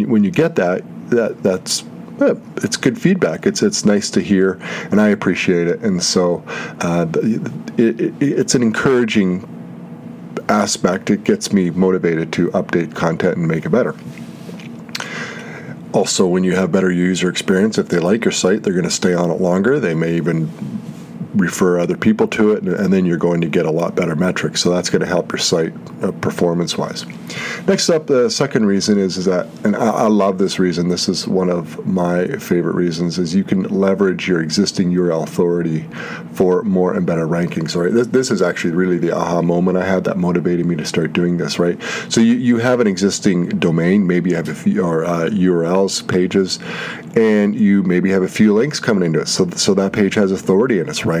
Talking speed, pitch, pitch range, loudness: 195 wpm, 90 Hz, 85-100 Hz, -16 LUFS